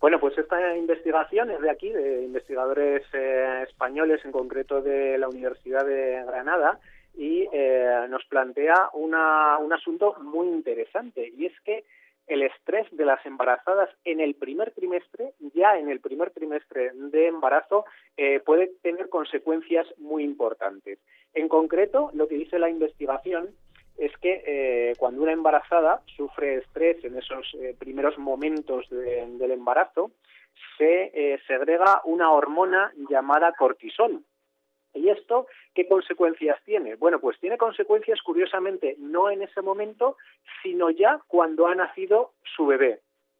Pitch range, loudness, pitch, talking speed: 135-190 Hz, -24 LUFS, 160 Hz, 140 wpm